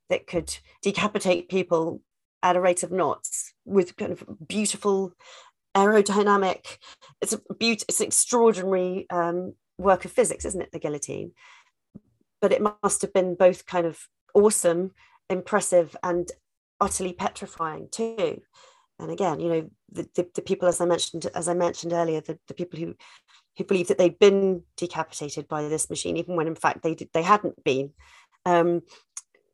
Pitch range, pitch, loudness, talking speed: 170-200 Hz, 180 Hz, -25 LUFS, 165 wpm